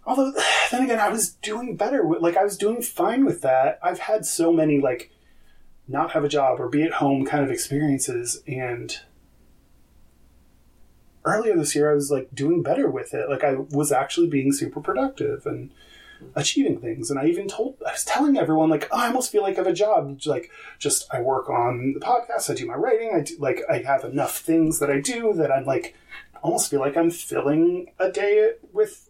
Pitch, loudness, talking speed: 170 Hz, -23 LUFS, 210 wpm